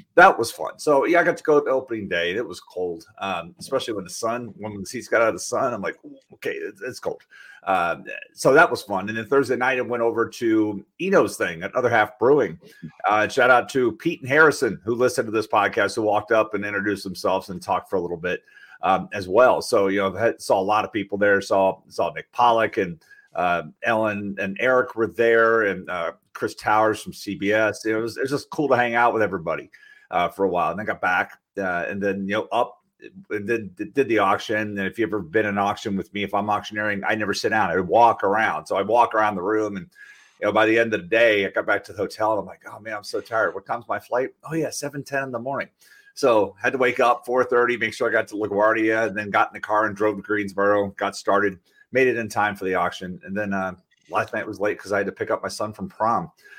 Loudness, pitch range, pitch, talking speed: -22 LUFS, 100-120 Hz, 110 Hz, 265 wpm